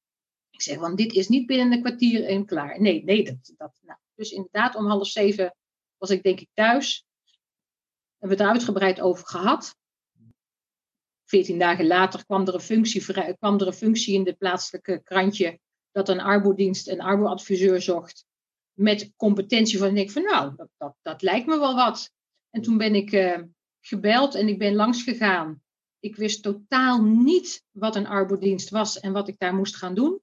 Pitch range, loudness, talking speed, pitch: 185-220 Hz, -23 LUFS, 185 wpm, 200 Hz